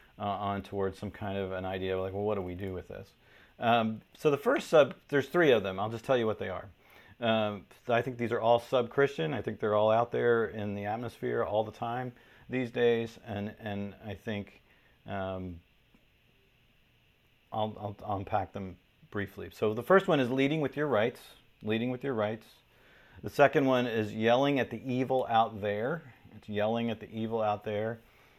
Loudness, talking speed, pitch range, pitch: -31 LUFS, 200 wpm, 100-120 Hz, 110 Hz